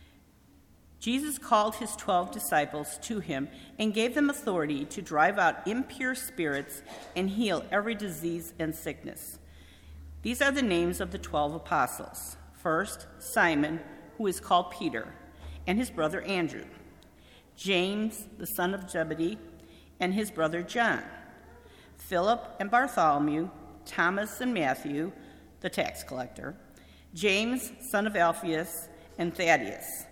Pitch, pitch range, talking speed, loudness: 175 Hz, 145-215 Hz, 130 wpm, -30 LUFS